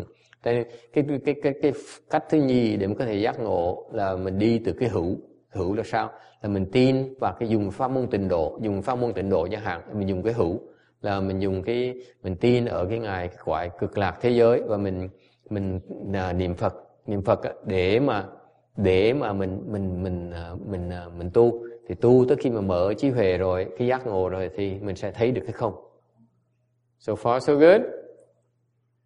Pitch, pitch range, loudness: 110 Hz, 95-120 Hz, -25 LUFS